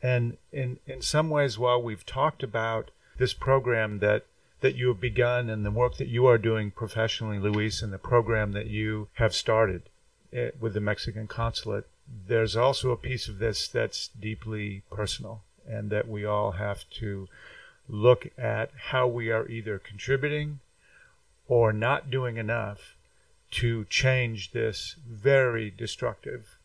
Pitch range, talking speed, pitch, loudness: 105-125 Hz, 150 wpm, 115 Hz, -28 LUFS